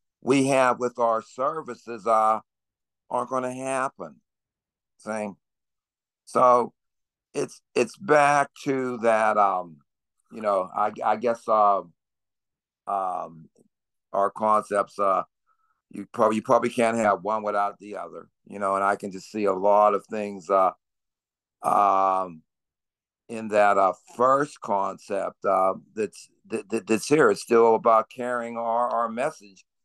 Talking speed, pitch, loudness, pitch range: 140 wpm, 110 Hz, -24 LUFS, 100-120 Hz